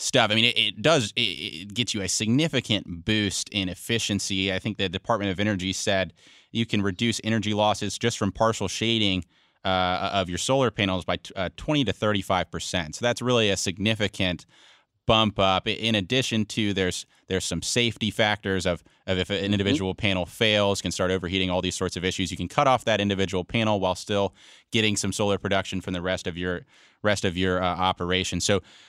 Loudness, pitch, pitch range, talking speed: -25 LUFS, 100 Hz, 95-110 Hz, 200 wpm